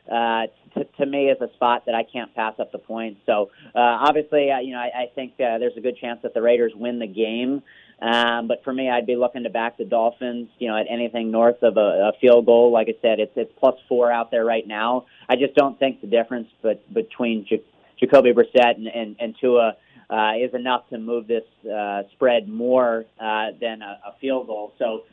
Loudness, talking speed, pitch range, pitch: -21 LUFS, 230 wpm, 115-125 Hz, 120 Hz